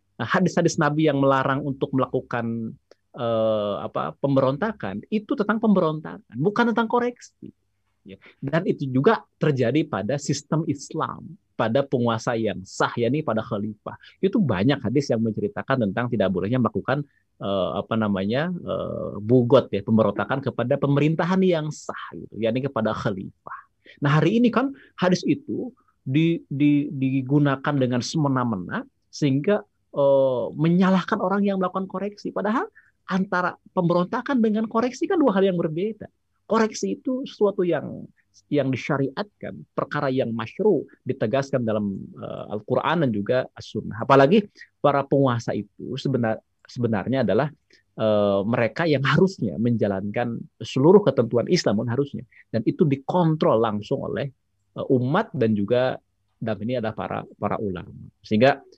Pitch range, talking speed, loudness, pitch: 115-180 Hz, 130 wpm, -23 LUFS, 135 Hz